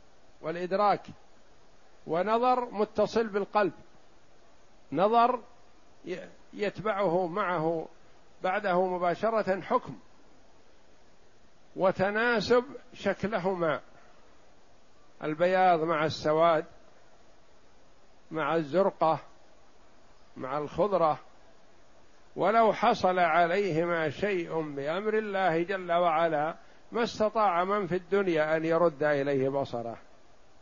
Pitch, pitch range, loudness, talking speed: 185 Hz, 165-210 Hz, -28 LUFS, 70 wpm